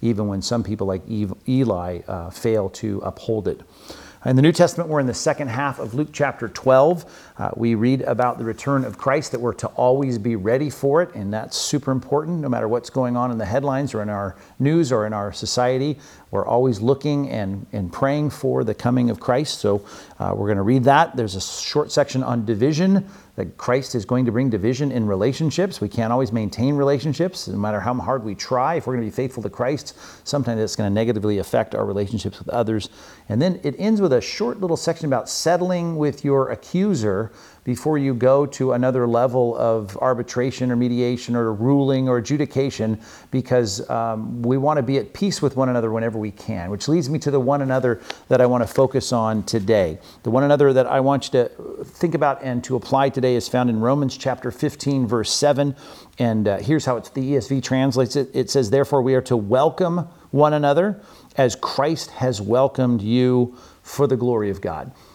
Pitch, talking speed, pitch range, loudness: 125 Hz, 210 wpm, 115-140 Hz, -21 LUFS